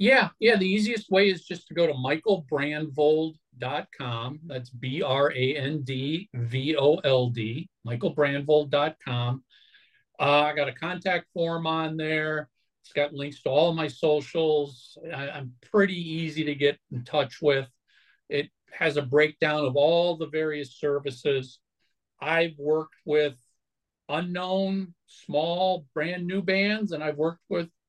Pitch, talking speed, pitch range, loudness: 150 Hz, 145 wpm, 140-170 Hz, -26 LUFS